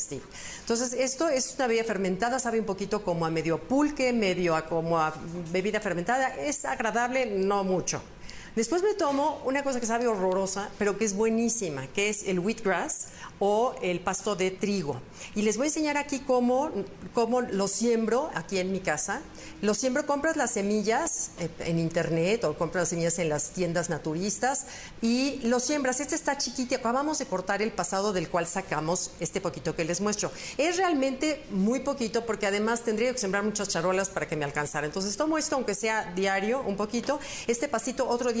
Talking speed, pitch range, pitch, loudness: 190 wpm, 180-255 Hz, 210 Hz, -28 LUFS